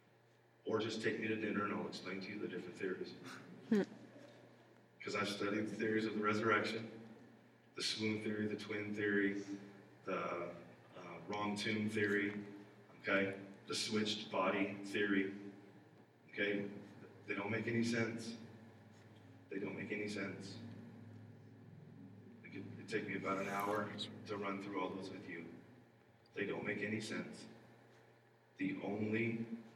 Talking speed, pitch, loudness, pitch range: 145 wpm, 105 Hz, -41 LUFS, 100-115 Hz